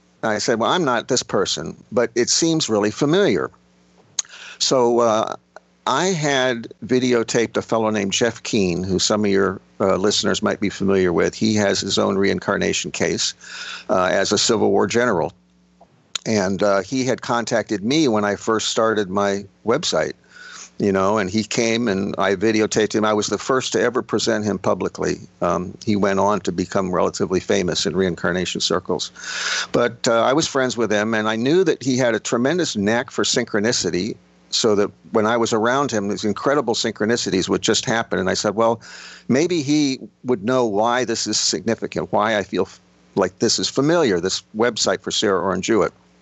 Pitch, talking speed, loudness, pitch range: 110 Hz, 185 wpm, -20 LUFS, 100-120 Hz